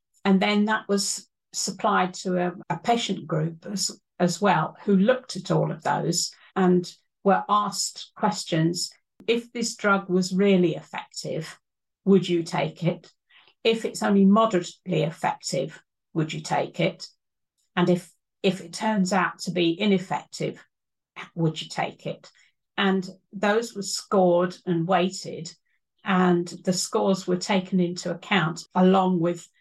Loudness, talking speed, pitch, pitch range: -25 LUFS, 140 wpm, 185 Hz, 175-200 Hz